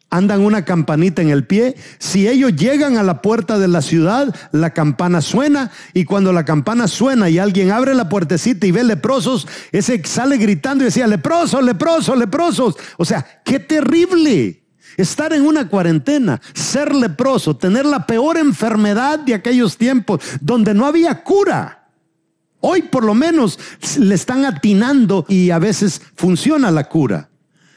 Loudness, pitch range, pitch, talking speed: -15 LUFS, 185-265 Hz, 225 Hz, 160 wpm